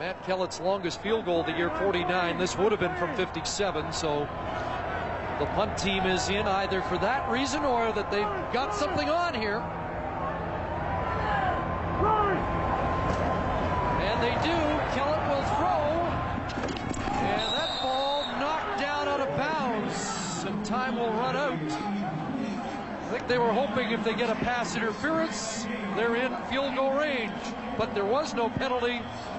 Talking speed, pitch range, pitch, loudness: 145 wpm, 195-255 Hz, 225 Hz, -28 LUFS